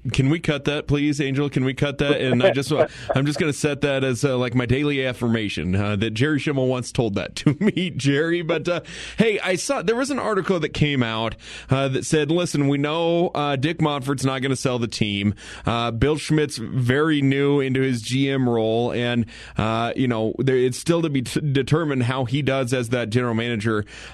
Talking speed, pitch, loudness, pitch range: 220 wpm, 135 Hz, -22 LUFS, 125-150 Hz